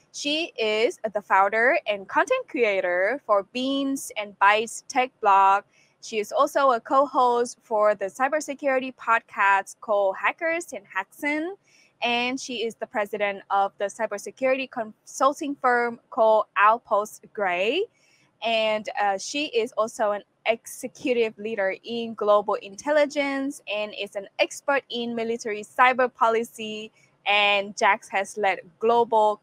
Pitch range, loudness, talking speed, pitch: 205-260 Hz, -24 LUFS, 130 wpm, 220 Hz